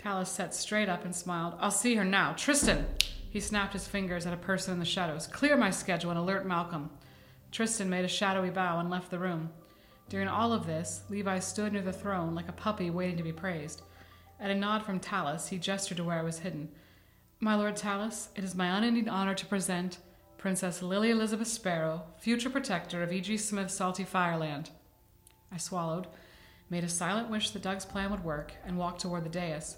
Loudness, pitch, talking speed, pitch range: -32 LUFS, 185 Hz, 205 wpm, 170-200 Hz